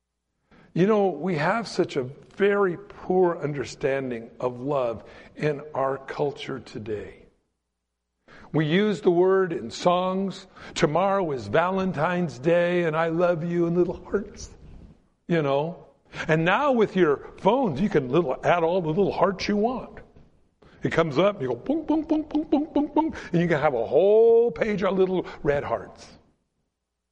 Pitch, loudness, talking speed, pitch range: 175 Hz, -24 LUFS, 160 wpm, 150-200 Hz